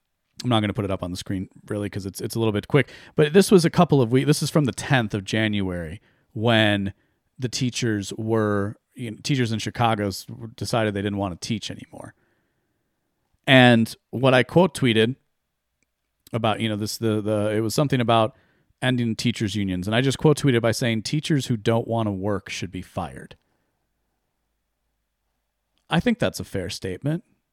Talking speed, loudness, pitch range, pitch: 190 wpm, -22 LUFS, 100-125 Hz, 110 Hz